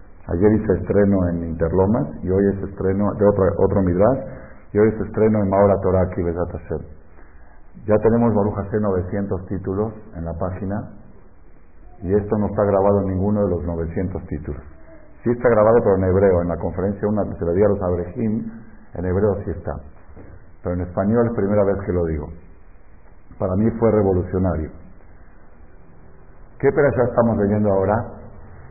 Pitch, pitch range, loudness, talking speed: 95 Hz, 85-105 Hz, -20 LUFS, 165 wpm